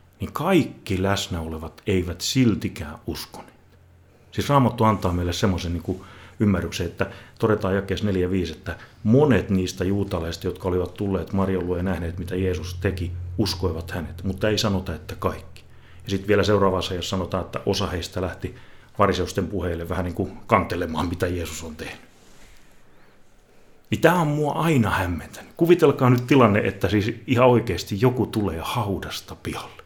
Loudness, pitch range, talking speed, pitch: -23 LUFS, 90-105 Hz, 155 wpm, 95 Hz